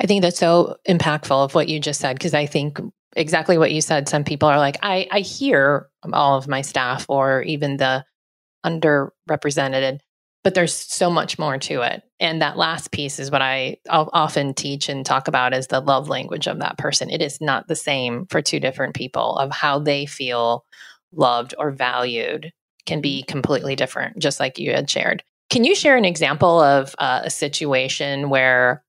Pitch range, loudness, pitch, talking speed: 135-160 Hz, -20 LUFS, 145 Hz, 195 wpm